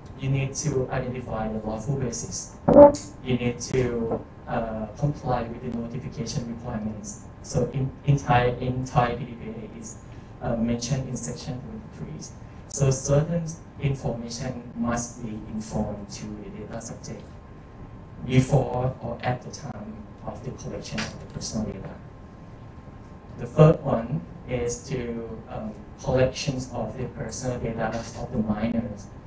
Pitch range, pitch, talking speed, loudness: 110-130 Hz, 120 Hz, 130 wpm, -26 LUFS